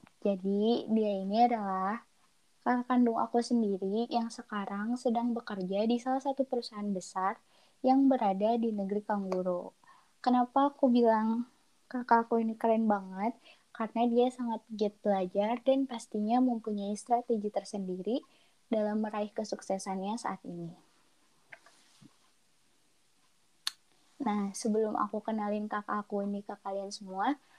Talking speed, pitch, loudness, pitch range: 115 wpm, 220 Hz, -32 LUFS, 205-240 Hz